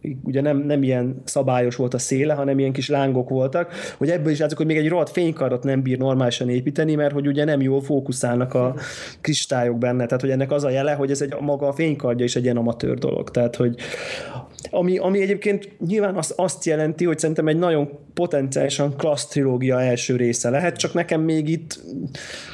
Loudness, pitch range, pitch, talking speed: -21 LUFS, 130-160 Hz, 140 Hz, 200 wpm